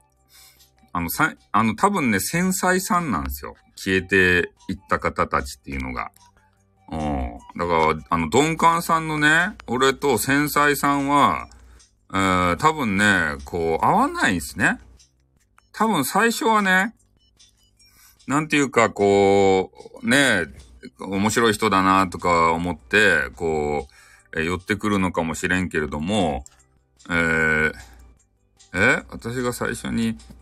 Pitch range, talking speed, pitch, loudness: 80-115 Hz, 235 characters per minute, 95 Hz, -20 LUFS